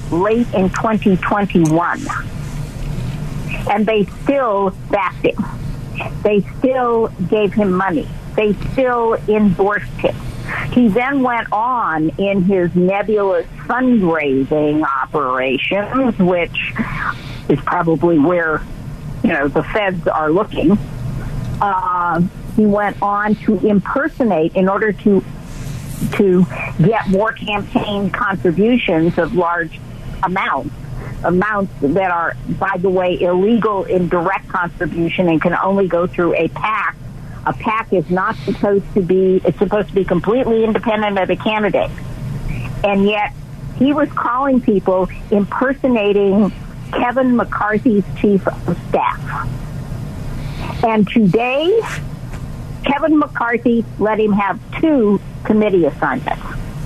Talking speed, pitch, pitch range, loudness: 115 wpm, 195 Hz, 160-215 Hz, -16 LUFS